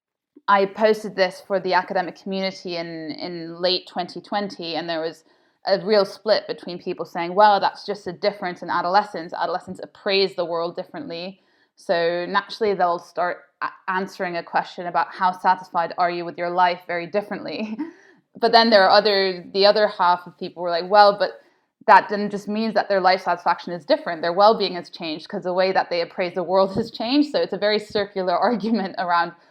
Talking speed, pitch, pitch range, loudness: 195 wpm, 185 Hz, 175-205 Hz, -21 LUFS